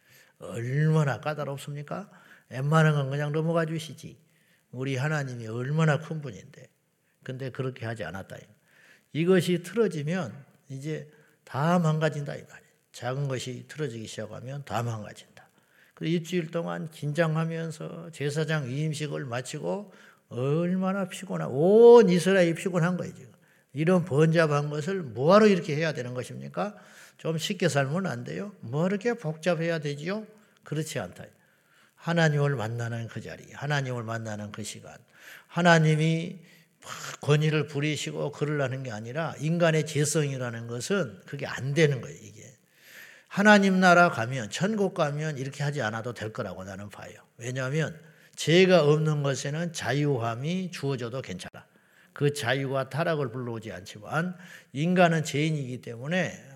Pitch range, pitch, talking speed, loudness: 130-170 Hz, 150 Hz, 305 characters per minute, -27 LUFS